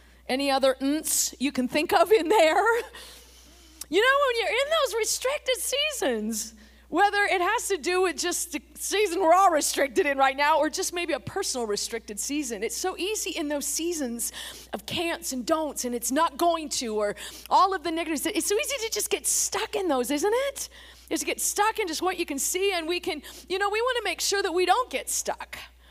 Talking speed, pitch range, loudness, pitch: 220 wpm, 280-395 Hz, -25 LUFS, 335 Hz